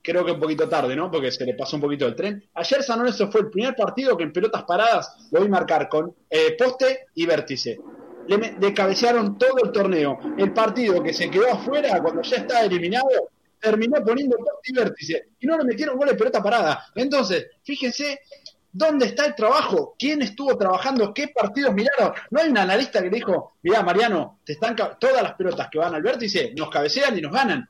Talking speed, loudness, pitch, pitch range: 205 wpm, -22 LUFS, 235 Hz, 190-275 Hz